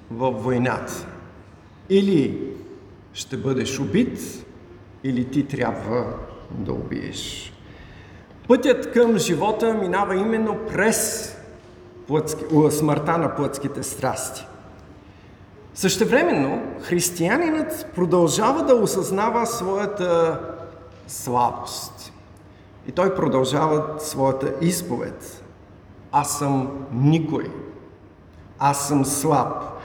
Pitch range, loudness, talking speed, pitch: 115-185 Hz, -22 LUFS, 80 wpm, 140 Hz